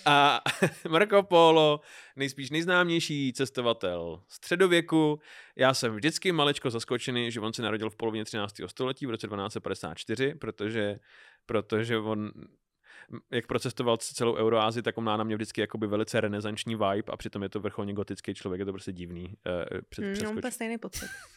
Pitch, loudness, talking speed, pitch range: 115 Hz, -29 LUFS, 150 wpm, 105-145 Hz